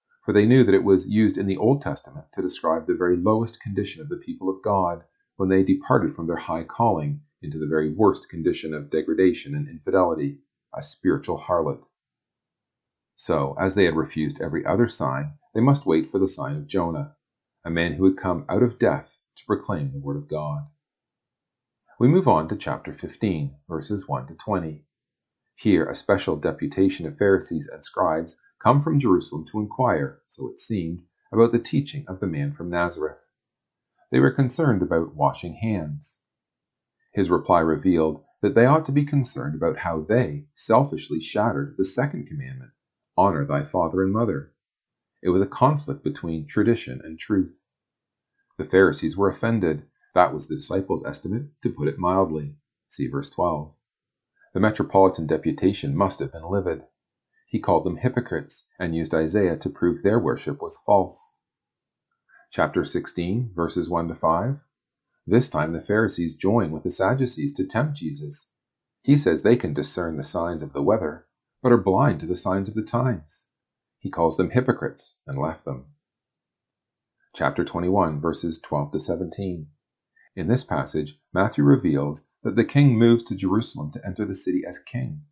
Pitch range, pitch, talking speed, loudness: 80-120 Hz, 95 Hz, 170 wpm, -23 LUFS